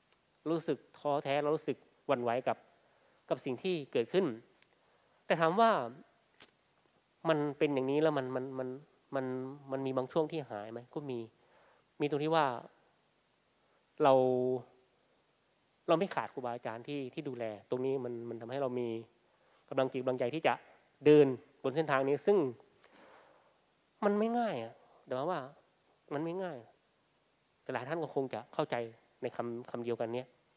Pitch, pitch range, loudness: 135 Hz, 125-155 Hz, -34 LUFS